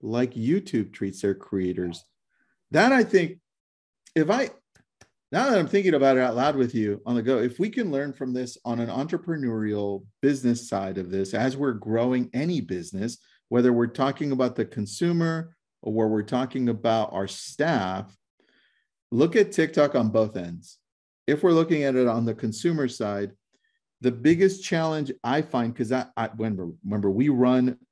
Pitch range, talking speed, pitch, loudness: 110-150 Hz, 175 wpm, 125 Hz, -25 LUFS